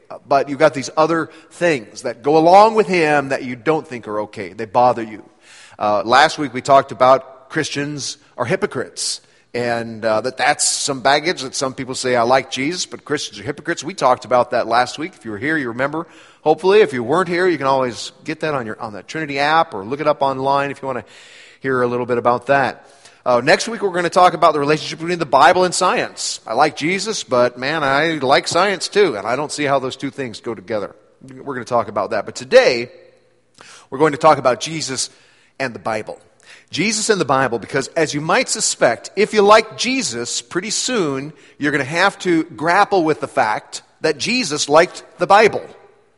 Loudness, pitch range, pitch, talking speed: -17 LUFS, 130-175 Hz, 150 Hz, 220 wpm